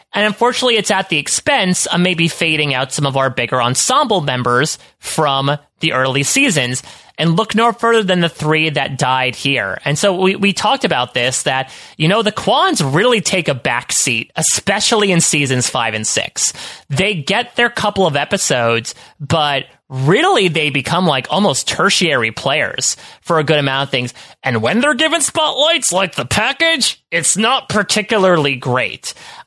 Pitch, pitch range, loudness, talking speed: 160 Hz, 135-210 Hz, -14 LUFS, 170 wpm